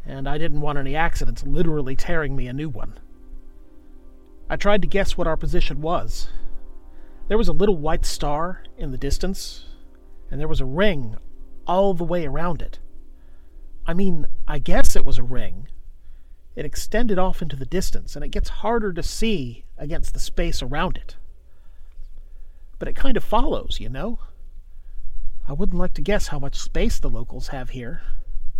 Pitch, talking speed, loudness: 140 Hz, 175 wpm, -26 LUFS